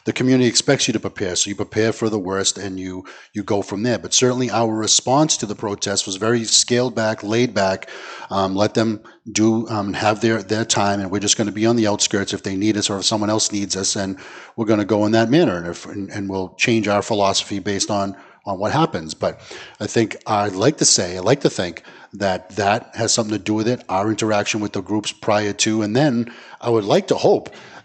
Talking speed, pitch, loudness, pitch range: 240 wpm, 105 Hz, -19 LUFS, 100-115 Hz